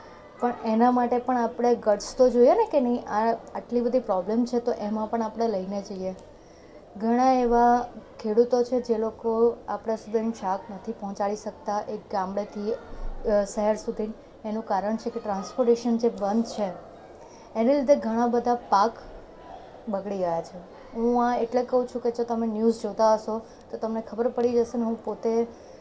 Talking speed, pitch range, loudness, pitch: 170 wpm, 210-240 Hz, -26 LUFS, 230 Hz